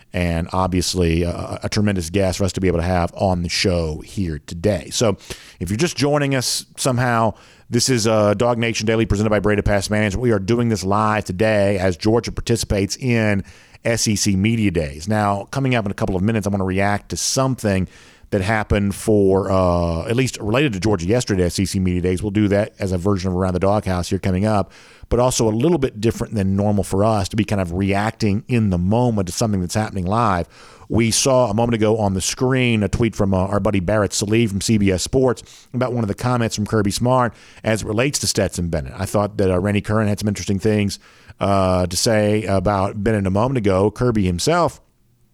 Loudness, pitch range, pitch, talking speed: -19 LUFS, 95-115 Hz, 105 Hz, 220 wpm